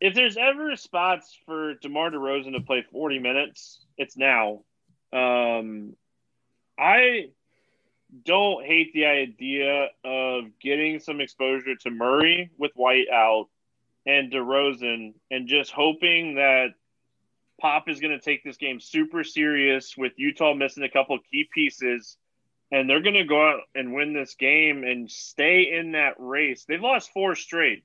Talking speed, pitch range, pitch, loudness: 150 wpm, 130-155 Hz, 140 Hz, -23 LUFS